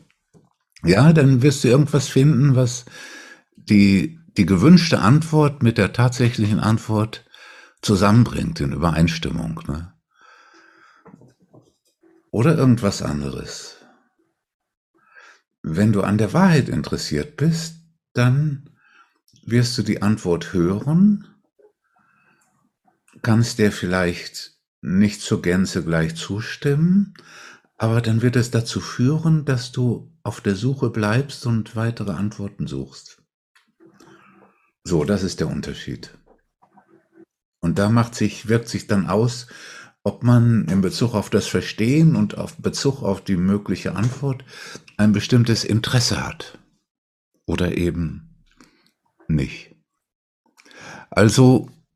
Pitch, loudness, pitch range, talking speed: 115 Hz, -19 LUFS, 100-145 Hz, 110 wpm